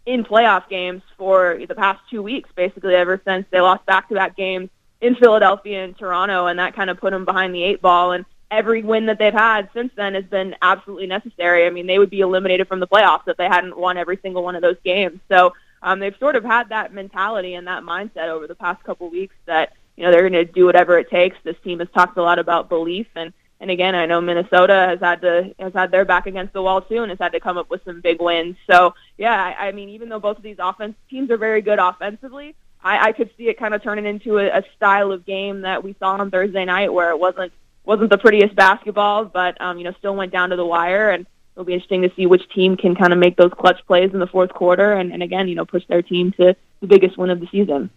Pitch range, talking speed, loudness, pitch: 180-200 Hz, 265 wpm, -17 LUFS, 185 Hz